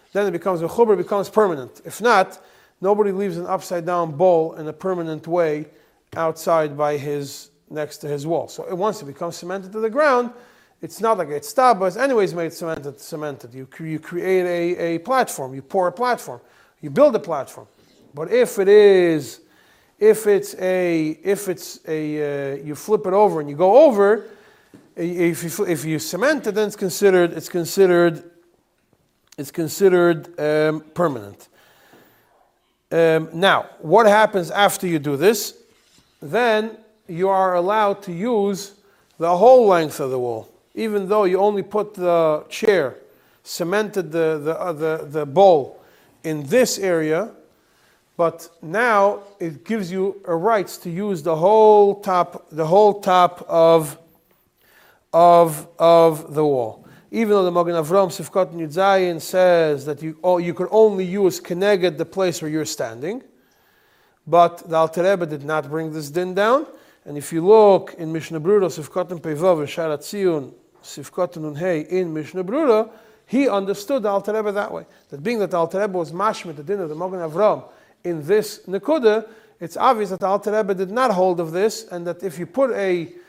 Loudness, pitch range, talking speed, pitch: -19 LUFS, 165-205 Hz, 165 wpm, 180 Hz